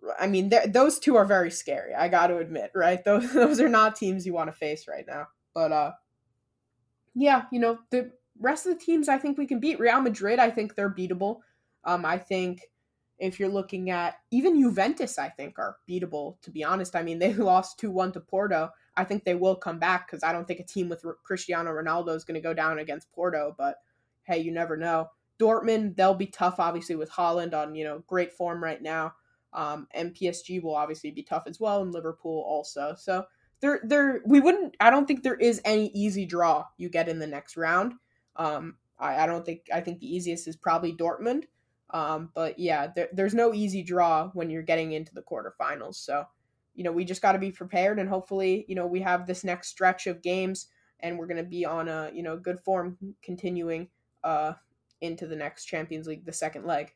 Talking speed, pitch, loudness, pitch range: 220 wpm, 180 Hz, -27 LUFS, 160-200 Hz